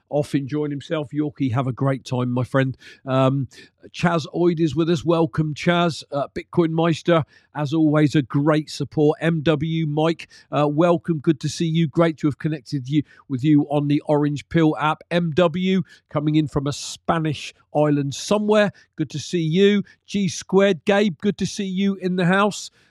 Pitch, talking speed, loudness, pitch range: 155 Hz, 180 wpm, -21 LUFS, 145-170 Hz